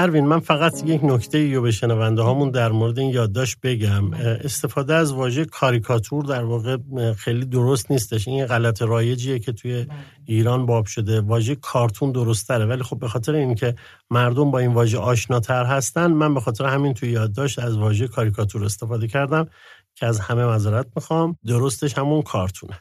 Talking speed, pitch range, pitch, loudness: 170 wpm, 115-140 Hz, 125 Hz, -21 LUFS